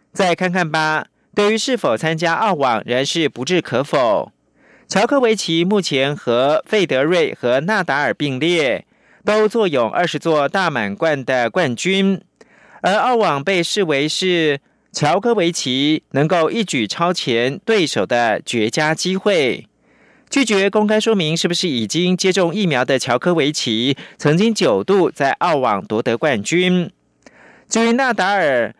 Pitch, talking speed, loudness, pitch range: 175 Hz, 220 characters per minute, -17 LUFS, 150-205 Hz